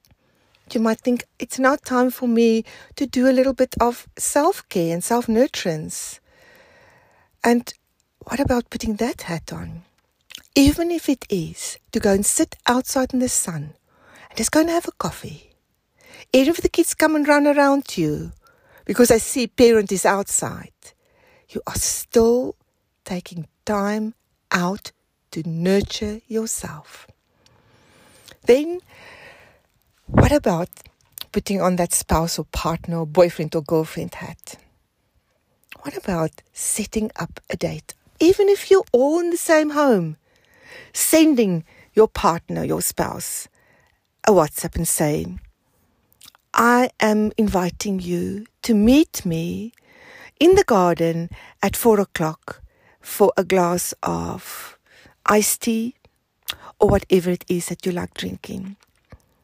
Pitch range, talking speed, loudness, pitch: 180-270 Hz, 135 wpm, -20 LUFS, 220 Hz